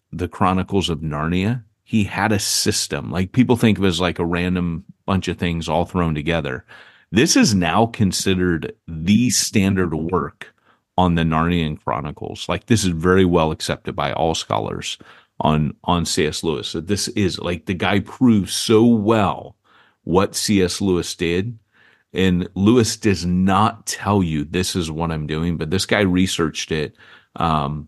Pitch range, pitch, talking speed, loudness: 85-105 Hz, 90 Hz, 165 wpm, -19 LUFS